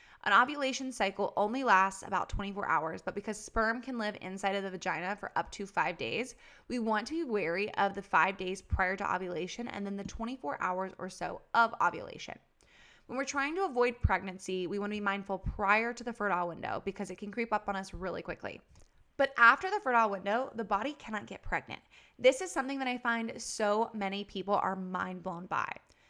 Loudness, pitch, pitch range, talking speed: -32 LUFS, 205 Hz, 195-235 Hz, 210 wpm